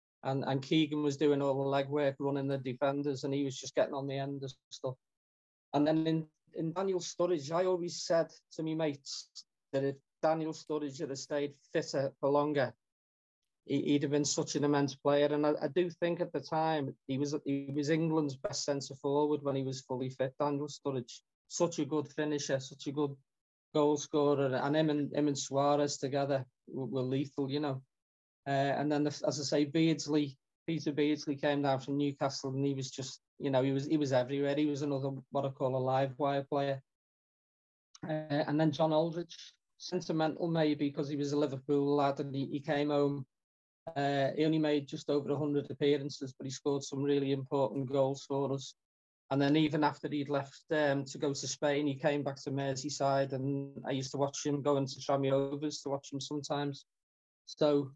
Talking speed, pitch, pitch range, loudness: 200 wpm, 145 Hz, 135-150 Hz, -34 LUFS